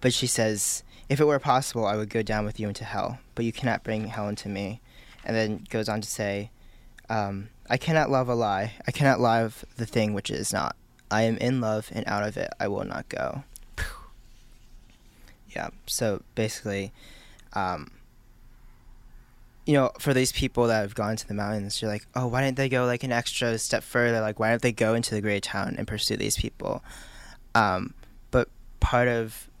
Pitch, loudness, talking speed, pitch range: 115 Hz, -27 LUFS, 200 wpm, 105-125 Hz